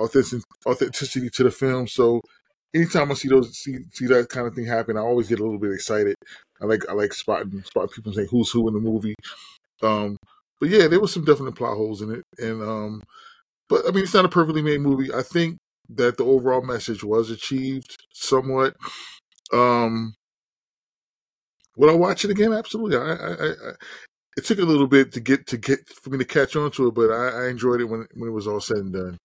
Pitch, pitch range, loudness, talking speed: 125 Hz, 110-140 Hz, -22 LUFS, 220 wpm